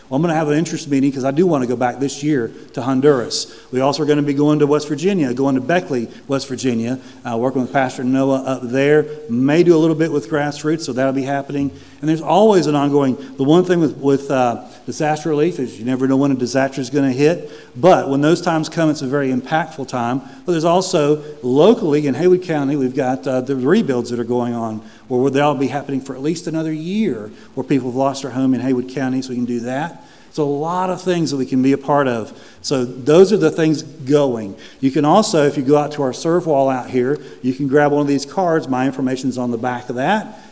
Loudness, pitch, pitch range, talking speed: -17 LUFS, 140 Hz, 130-150 Hz, 255 wpm